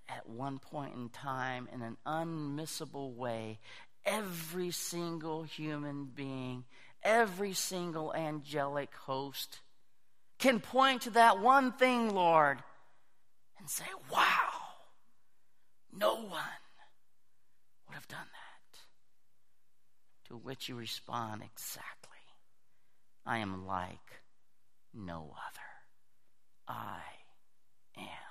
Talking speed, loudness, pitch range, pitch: 95 wpm, -34 LUFS, 125-175 Hz, 145 Hz